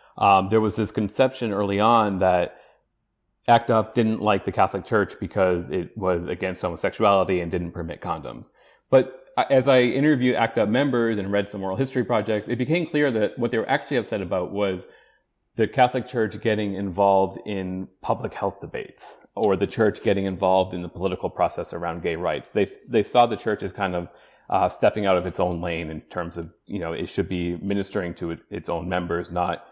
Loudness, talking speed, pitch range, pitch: -23 LUFS, 200 wpm, 90-115 Hz, 100 Hz